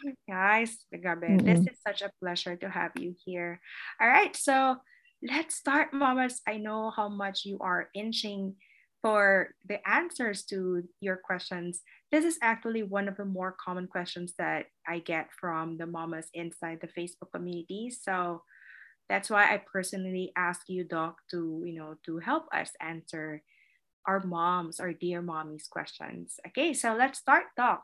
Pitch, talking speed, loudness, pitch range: 185 Hz, 160 wpm, -30 LUFS, 175-220 Hz